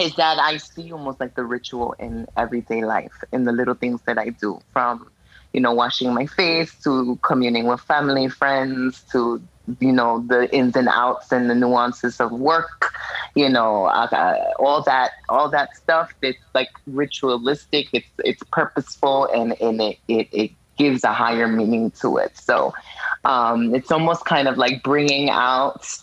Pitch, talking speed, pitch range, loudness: 125 Hz, 170 wpm, 120-140 Hz, -20 LUFS